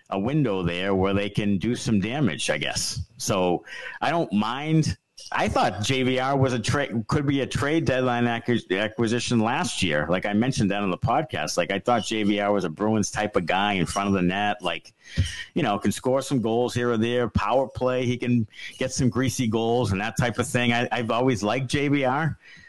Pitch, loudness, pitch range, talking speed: 120 Hz, -24 LUFS, 100-130 Hz, 210 wpm